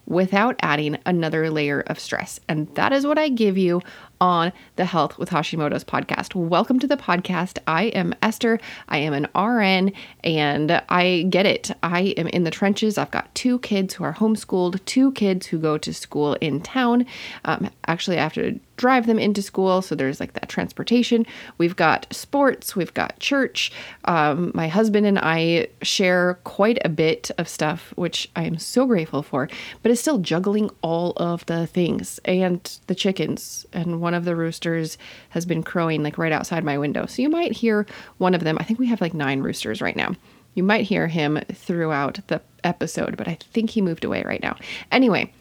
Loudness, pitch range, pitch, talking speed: -22 LUFS, 160-220 Hz, 180 Hz, 190 wpm